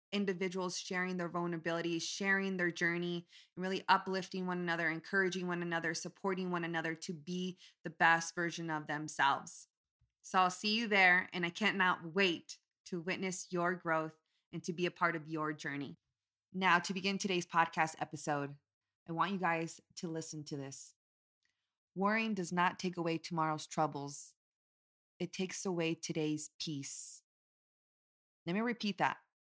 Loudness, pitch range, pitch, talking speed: -35 LUFS, 160-185 Hz, 170 Hz, 155 wpm